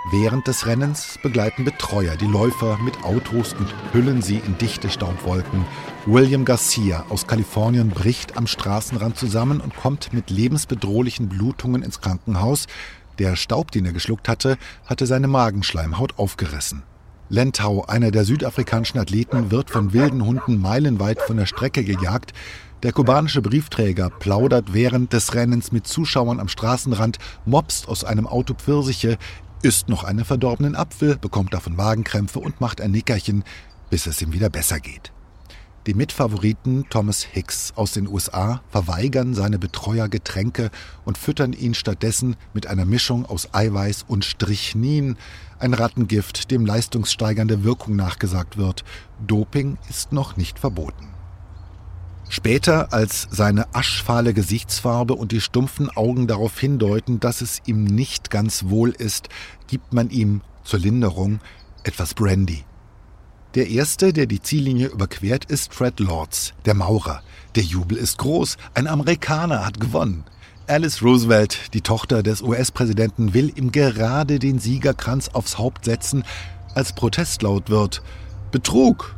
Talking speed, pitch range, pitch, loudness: 140 wpm, 100-125 Hz, 110 Hz, -21 LUFS